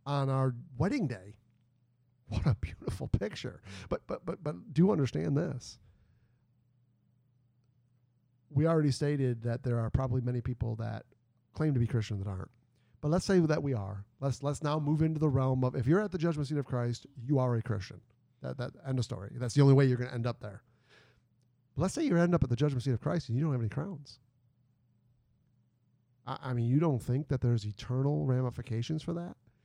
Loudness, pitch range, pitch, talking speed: -32 LUFS, 120-145 Hz, 125 Hz, 205 wpm